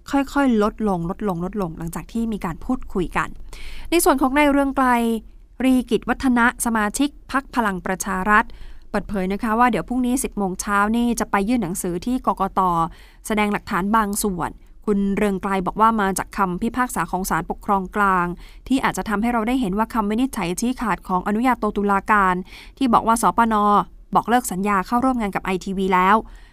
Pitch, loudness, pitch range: 210 Hz, -21 LUFS, 190-240 Hz